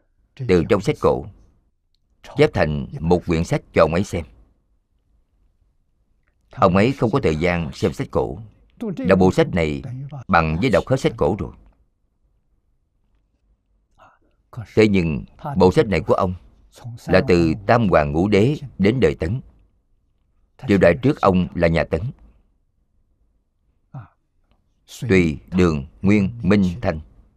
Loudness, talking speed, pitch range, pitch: -19 LUFS, 135 wpm, 80-100 Hz, 90 Hz